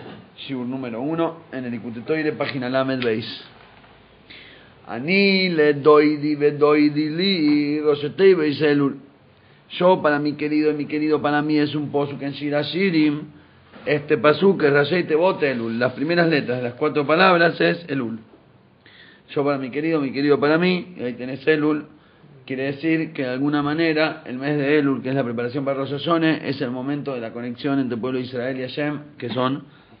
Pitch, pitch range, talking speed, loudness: 150 Hz, 135-155 Hz, 175 wpm, -21 LUFS